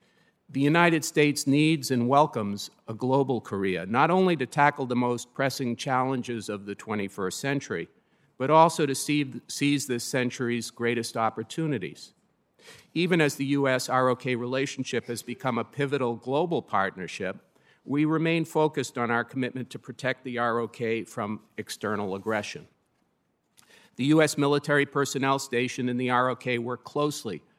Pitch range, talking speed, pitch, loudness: 120-145 Hz, 140 wpm, 130 Hz, -27 LUFS